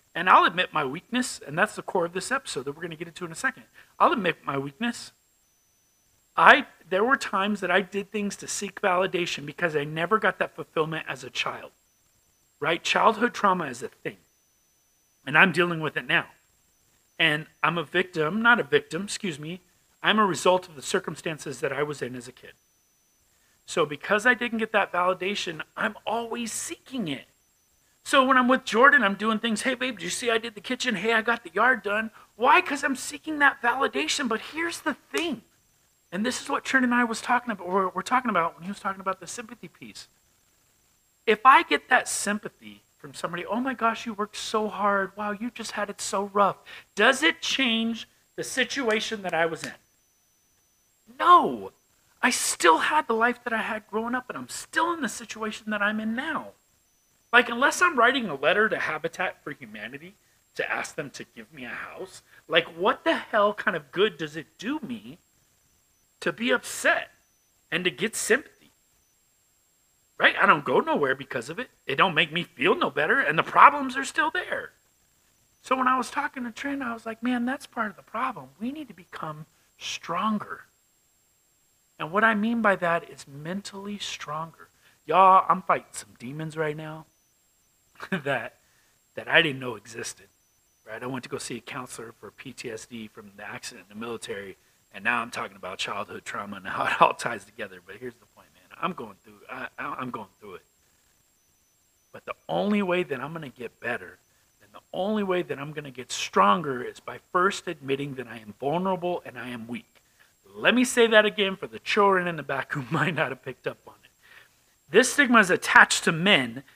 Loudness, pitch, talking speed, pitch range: -25 LUFS, 200 Hz, 200 wpm, 165-240 Hz